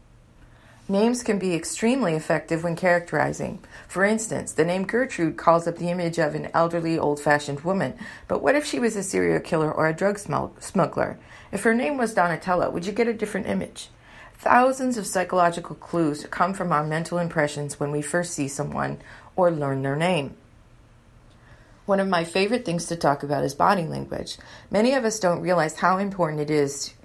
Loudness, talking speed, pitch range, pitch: -24 LUFS, 185 wpm, 145-195 Hz, 170 Hz